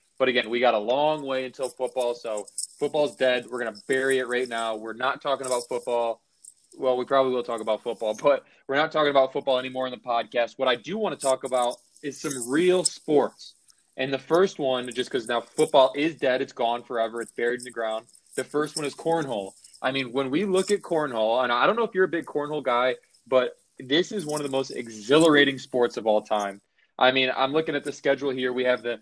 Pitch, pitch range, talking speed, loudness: 130 Hz, 120-145 Hz, 240 wpm, -25 LUFS